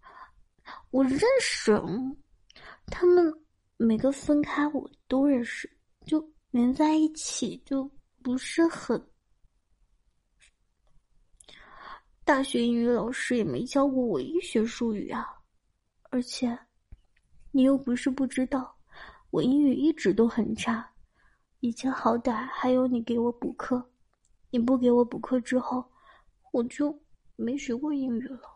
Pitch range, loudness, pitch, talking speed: 240-295 Hz, -27 LUFS, 260 Hz, 170 characters per minute